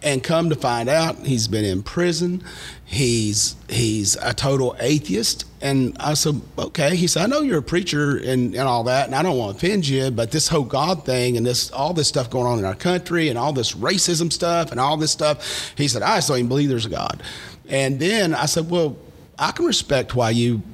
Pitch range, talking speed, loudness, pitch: 120-165 Hz, 230 wpm, -20 LUFS, 140 Hz